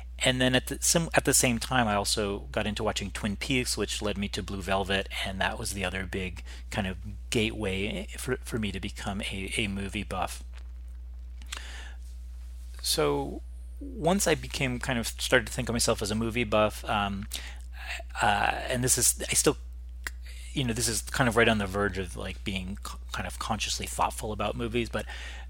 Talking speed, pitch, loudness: 195 wpm, 100 Hz, -28 LUFS